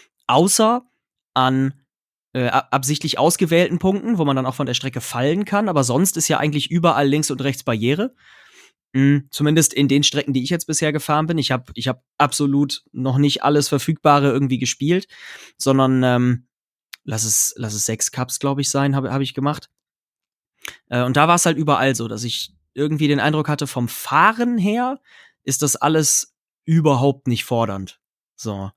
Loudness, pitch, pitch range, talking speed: -19 LUFS, 140 Hz, 130-155 Hz, 180 wpm